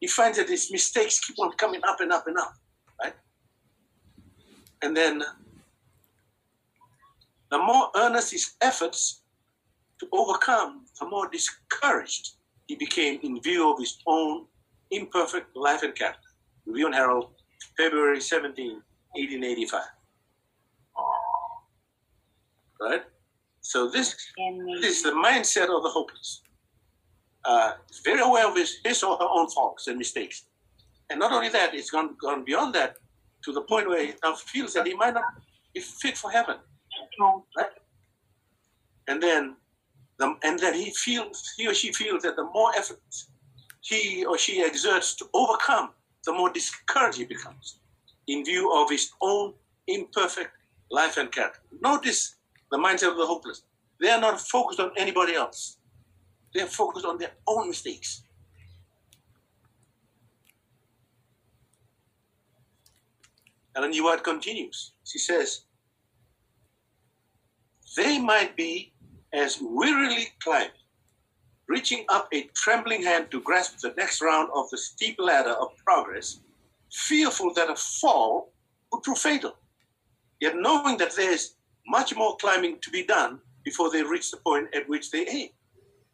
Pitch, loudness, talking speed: 170 Hz, -26 LUFS, 135 wpm